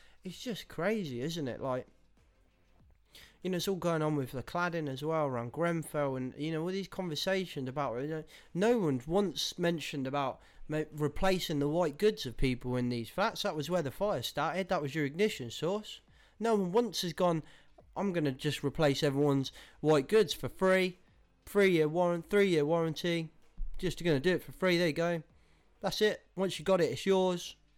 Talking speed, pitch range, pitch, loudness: 190 wpm, 145-185 Hz, 160 Hz, -32 LUFS